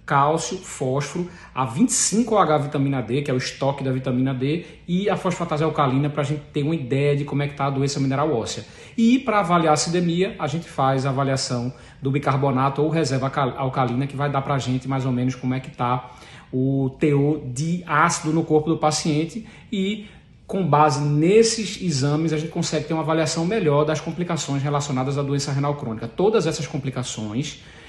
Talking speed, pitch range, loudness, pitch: 195 wpm, 135-160 Hz, -22 LUFS, 145 Hz